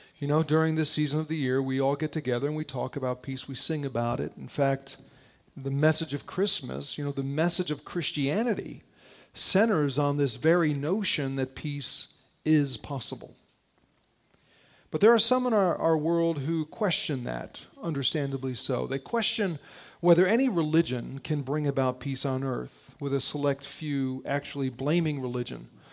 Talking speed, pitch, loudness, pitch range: 170 wpm, 145 Hz, -28 LUFS, 135-160 Hz